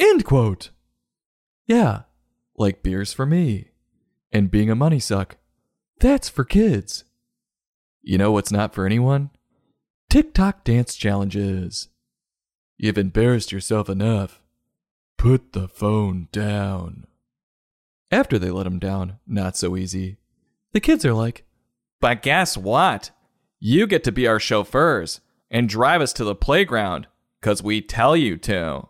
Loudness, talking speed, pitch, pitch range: -21 LUFS, 135 wpm, 105 Hz, 95-120 Hz